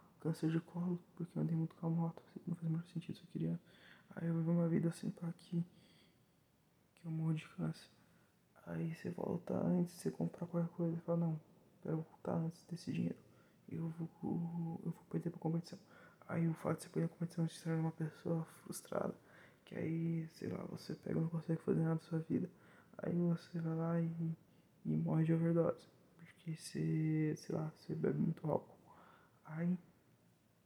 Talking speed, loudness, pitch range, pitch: 195 wpm, -41 LUFS, 160-175 Hz, 165 Hz